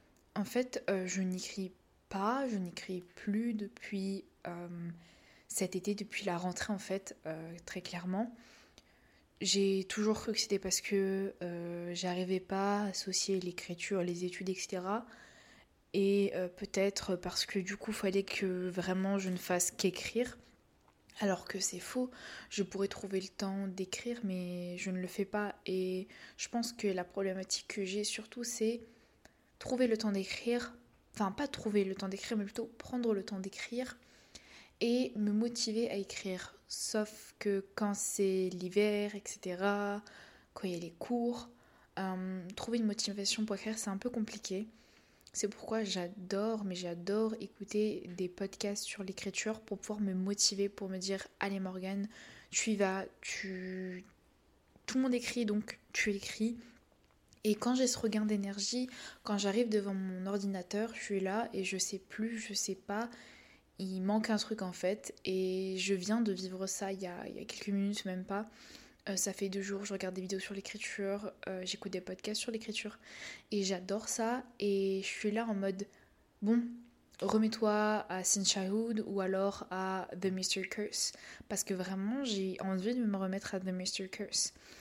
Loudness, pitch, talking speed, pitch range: -36 LUFS, 200 Hz, 170 wpm, 190-215 Hz